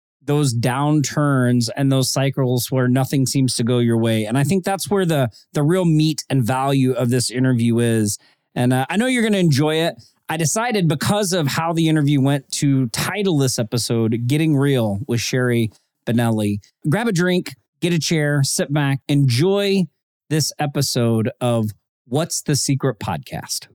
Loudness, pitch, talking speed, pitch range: -19 LUFS, 135 Hz, 170 wpm, 125-160 Hz